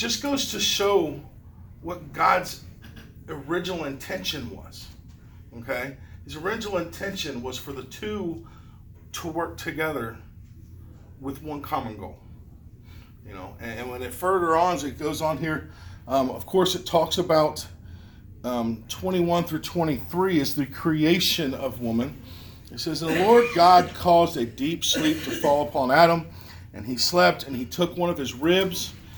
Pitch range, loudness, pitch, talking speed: 110-175 Hz, -24 LUFS, 140 Hz, 150 wpm